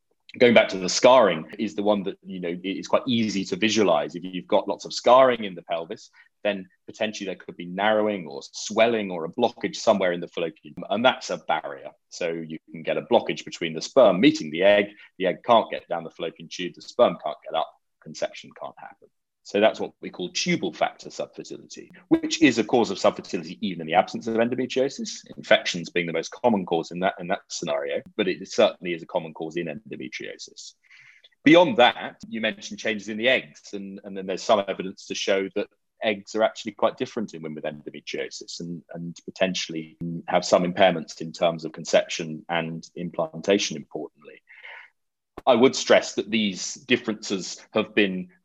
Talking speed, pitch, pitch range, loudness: 200 wpm, 95 Hz, 85-110 Hz, -24 LUFS